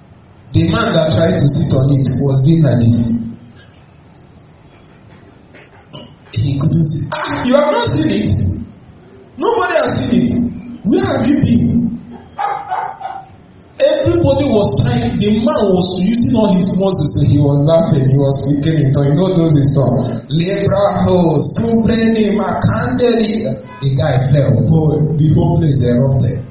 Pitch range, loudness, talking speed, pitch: 140-205 Hz, -13 LUFS, 160 wpm, 155 Hz